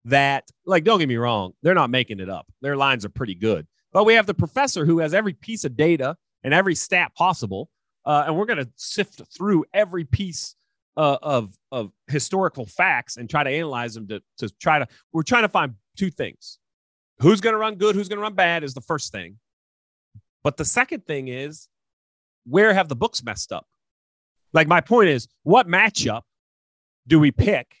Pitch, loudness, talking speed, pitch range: 145 Hz, -21 LUFS, 205 wpm, 110-185 Hz